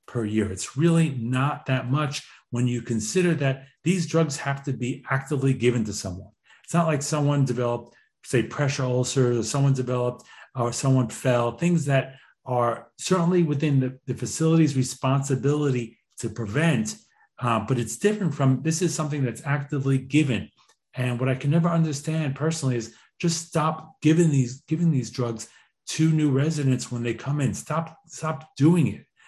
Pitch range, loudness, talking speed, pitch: 125-155 Hz, -25 LUFS, 170 wpm, 135 Hz